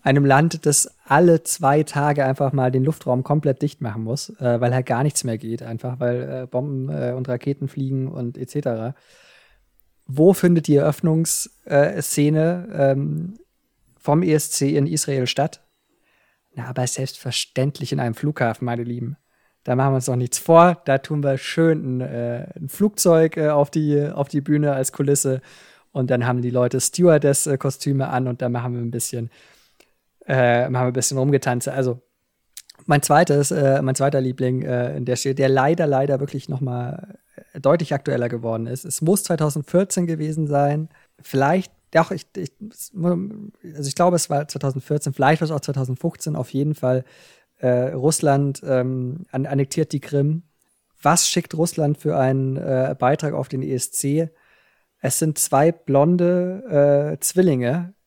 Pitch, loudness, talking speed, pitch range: 140 Hz, -20 LUFS, 155 wpm, 130-155 Hz